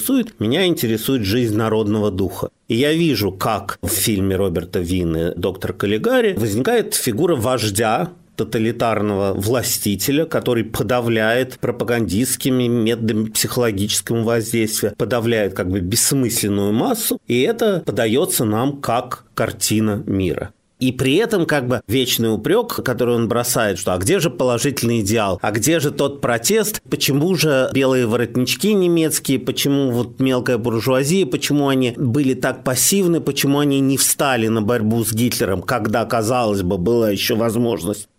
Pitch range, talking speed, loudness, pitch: 110-135 Hz, 135 wpm, -18 LUFS, 120 Hz